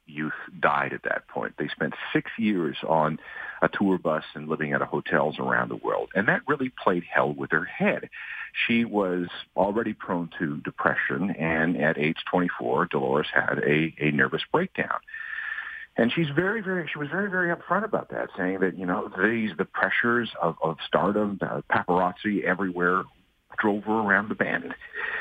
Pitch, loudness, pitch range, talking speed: 95 Hz, -26 LUFS, 85-120 Hz, 175 wpm